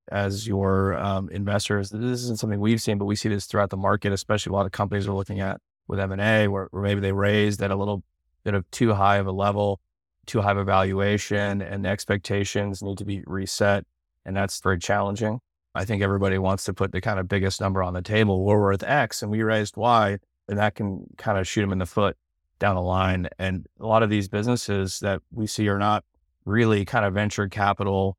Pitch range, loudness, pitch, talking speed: 95-105 Hz, -24 LUFS, 100 Hz, 230 wpm